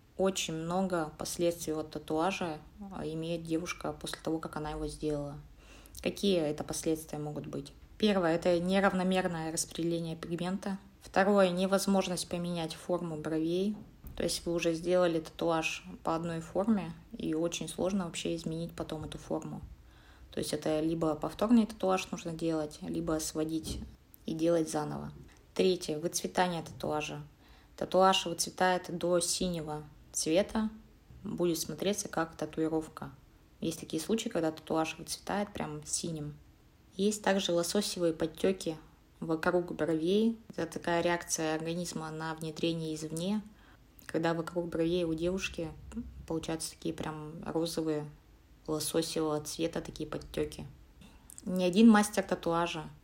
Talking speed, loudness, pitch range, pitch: 120 wpm, -33 LUFS, 160-185 Hz, 165 Hz